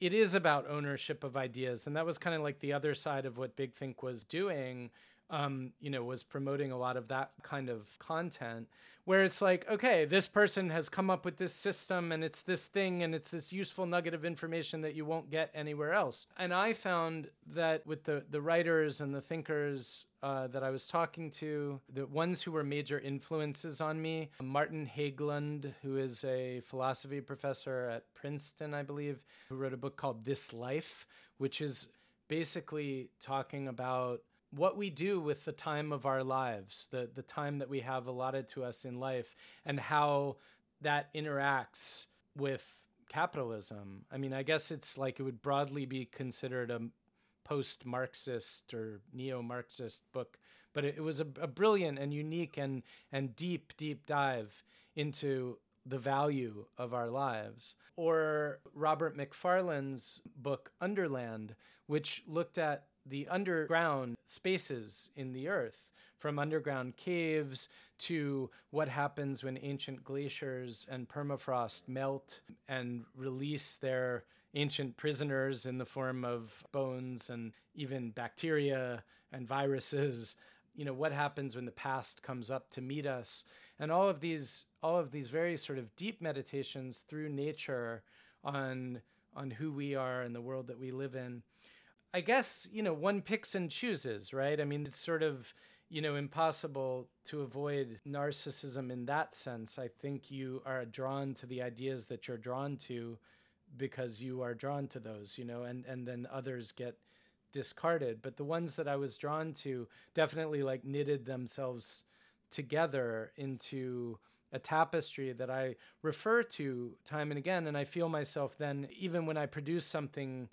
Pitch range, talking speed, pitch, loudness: 130-155 Hz, 165 wpm, 140 Hz, -37 LUFS